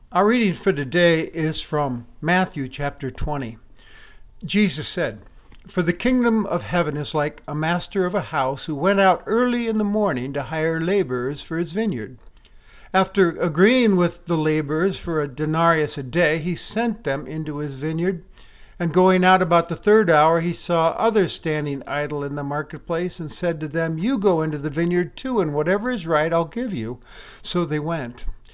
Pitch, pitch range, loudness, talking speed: 170 Hz, 150-190 Hz, -22 LUFS, 185 wpm